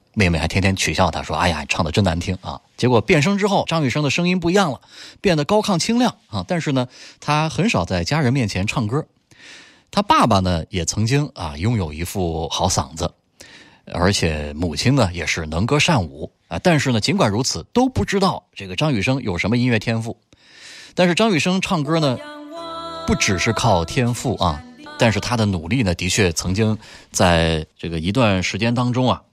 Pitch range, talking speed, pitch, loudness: 90-150 Hz, 285 characters per minute, 110 Hz, -19 LUFS